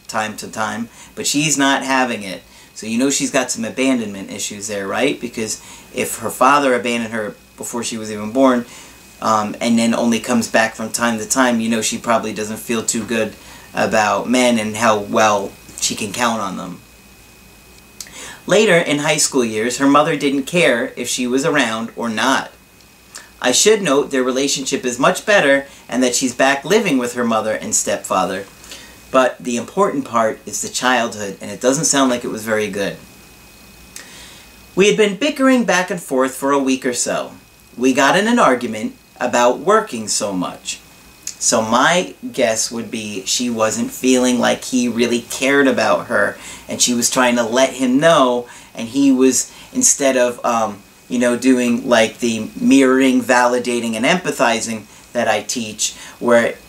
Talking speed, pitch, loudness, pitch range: 180 wpm, 125 Hz, -16 LUFS, 115-135 Hz